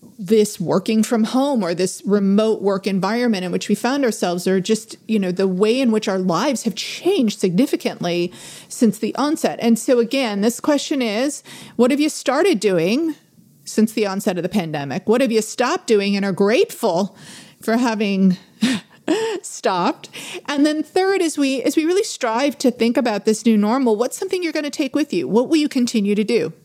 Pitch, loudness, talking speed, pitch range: 230 Hz, -19 LUFS, 195 wpm, 210-280 Hz